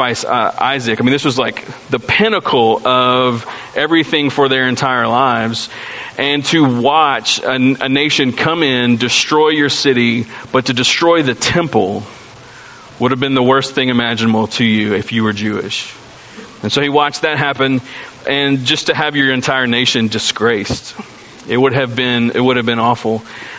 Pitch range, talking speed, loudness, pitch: 120-140 Hz, 170 wpm, -13 LUFS, 130 Hz